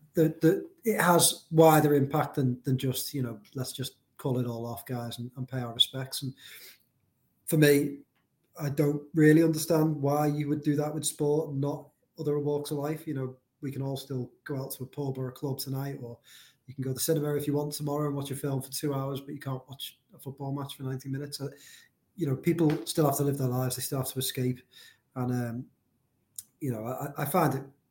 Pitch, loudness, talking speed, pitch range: 140 Hz, -29 LUFS, 235 wpm, 130-150 Hz